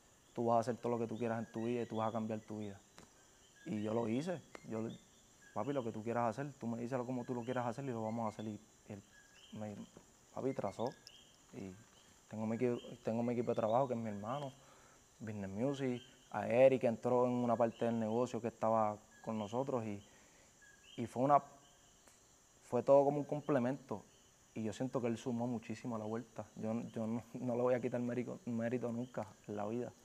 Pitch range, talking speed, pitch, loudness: 110-125 Hz, 220 wpm, 115 Hz, -39 LUFS